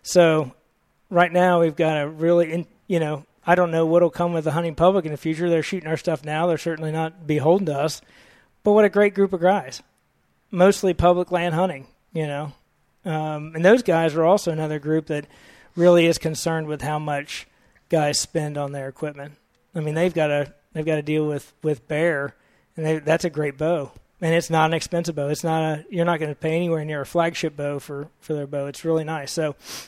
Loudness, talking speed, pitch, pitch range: -22 LUFS, 220 wpm, 160 Hz, 150-170 Hz